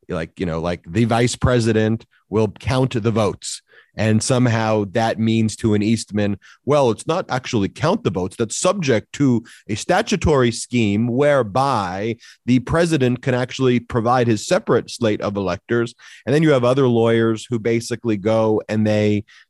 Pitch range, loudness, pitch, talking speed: 110-125 Hz, -19 LUFS, 115 Hz, 165 wpm